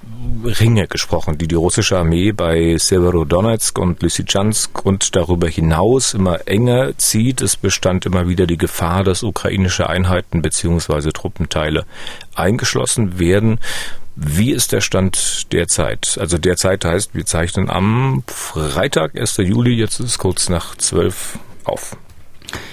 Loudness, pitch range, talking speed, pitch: -16 LUFS, 85-105 Hz, 130 wpm, 95 Hz